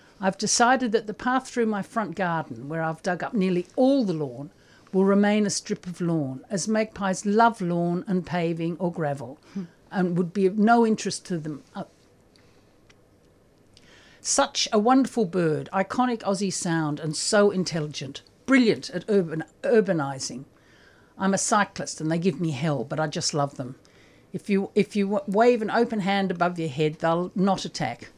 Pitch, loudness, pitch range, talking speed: 185 Hz, -25 LUFS, 155-205 Hz, 170 wpm